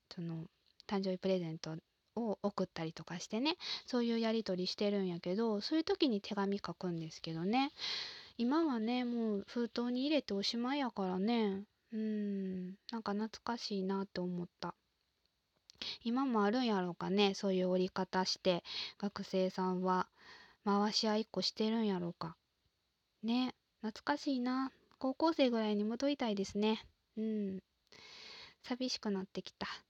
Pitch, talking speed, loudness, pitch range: 205 Hz, 310 characters per minute, -37 LUFS, 185-235 Hz